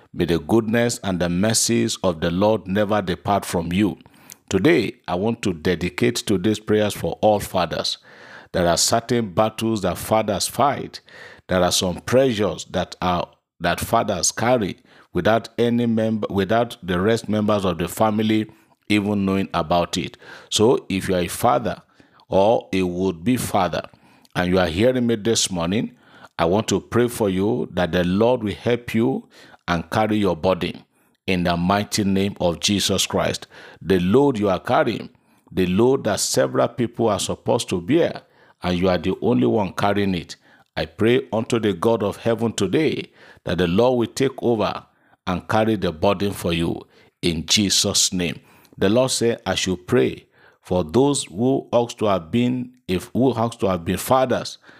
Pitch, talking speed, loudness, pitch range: 105 Hz, 175 wpm, -21 LUFS, 90-115 Hz